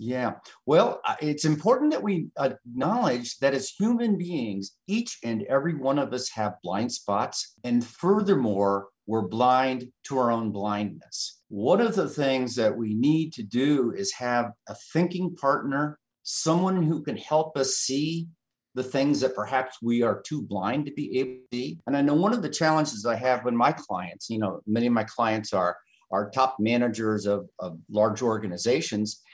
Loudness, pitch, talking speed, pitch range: -26 LUFS, 130 Hz, 175 wpm, 110-150 Hz